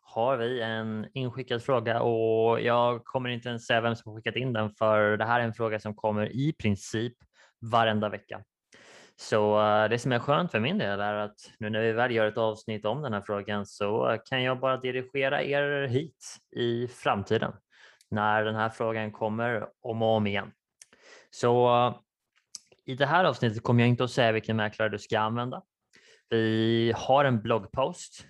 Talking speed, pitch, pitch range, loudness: 185 wpm, 115 Hz, 110-125 Hz, -28 LUFS